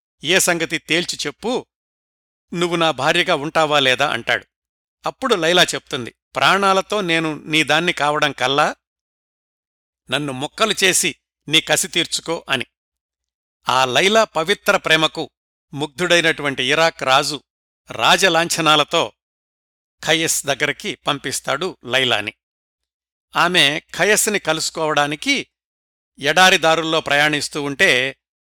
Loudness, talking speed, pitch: -17 LUFS, 95 wpm, 150 Hz